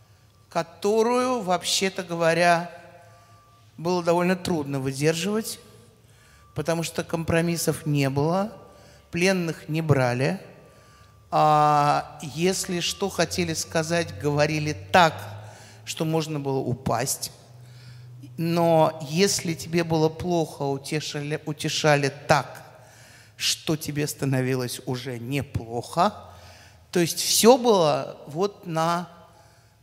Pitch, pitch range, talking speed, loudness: 155 Hz, 125-170 Hz, 90 wpm, -24 LUFS